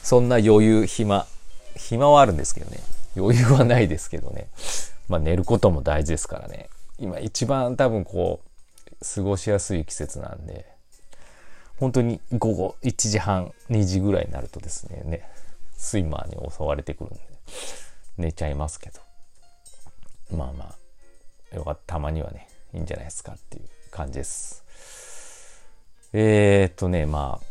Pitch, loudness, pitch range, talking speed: 90 Hz, -23 LUFS, 80-110 Hz, 295 characters per minute